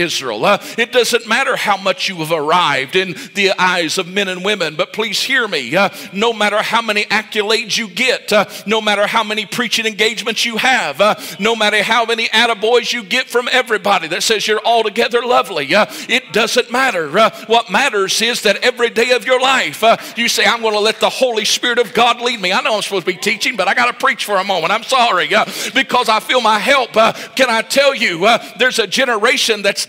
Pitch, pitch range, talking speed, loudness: 225 Hz, 205-240 Hz, 230 wpm, -14 LUFS